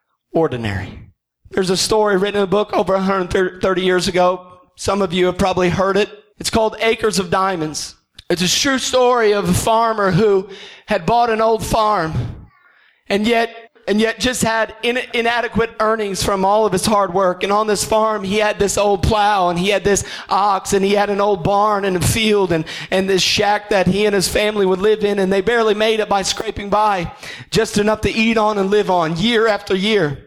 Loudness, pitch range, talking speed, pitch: -16 LUFS, 190-215 Hz, 210 wpm, 205 Hz